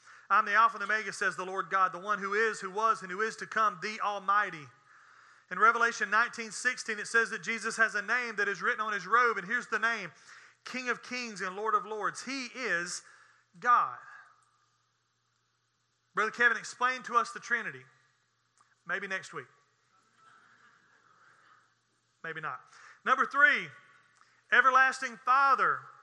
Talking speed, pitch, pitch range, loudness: 160 wpm, 230 Hz, 210-250 Hz, -29 LUFS